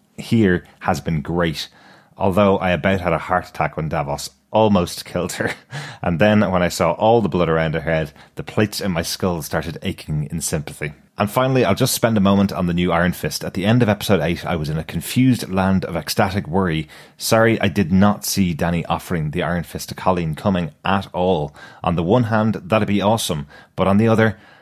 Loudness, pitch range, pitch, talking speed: -19 LUFS, 85-105 Hz, 95 Hz, 215 wpm